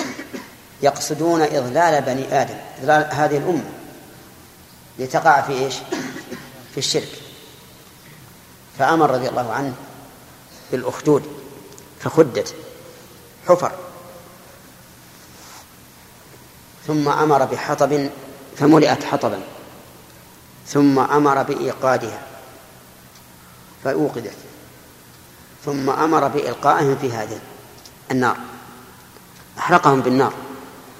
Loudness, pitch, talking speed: -19 LUFS, 135 Hz, 70 wpm